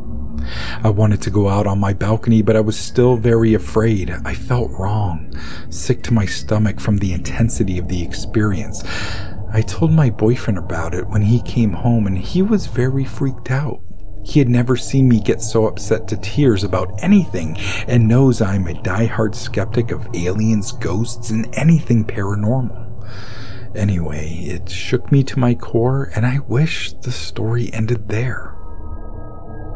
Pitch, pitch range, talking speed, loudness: 110 Hz, 100-120 Hz, 165 wpm, -18 LUFS